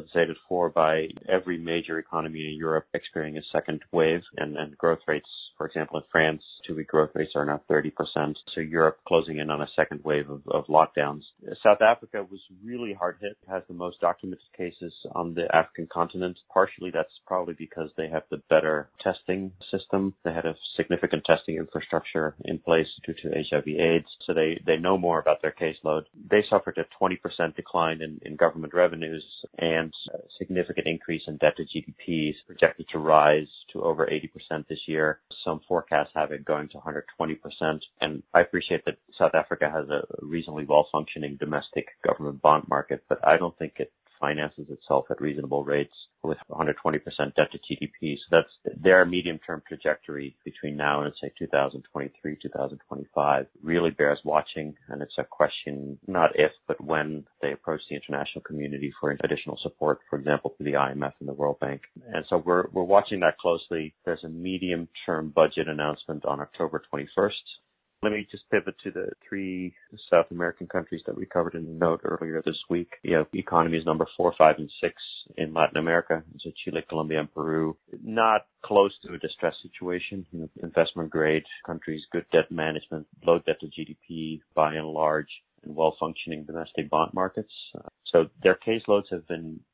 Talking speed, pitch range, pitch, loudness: 175 wpm, 75-85 Hz, 80 Hz, -27 LUFS